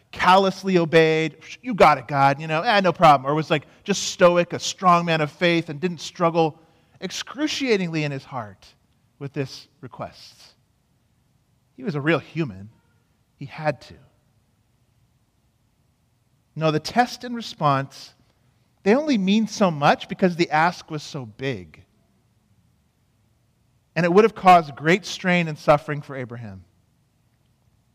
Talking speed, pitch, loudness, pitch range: 140 wpm, 145 Hz, -21 LUFS, 120-175 Hz